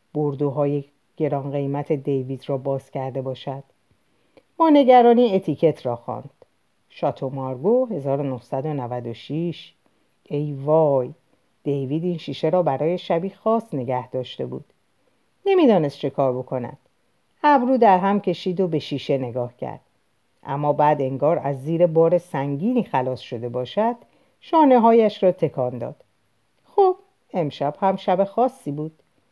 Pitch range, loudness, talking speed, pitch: 135-190 Hz, -21 LUFS, 125 wpm, 145 Hz